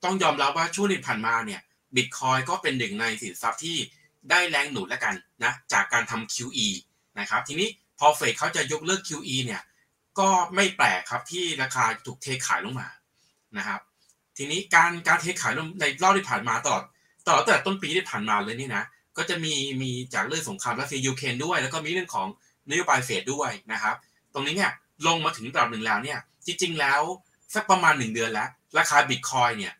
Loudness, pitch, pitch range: -25 LUFS, 155 Hz, 130-180 Hz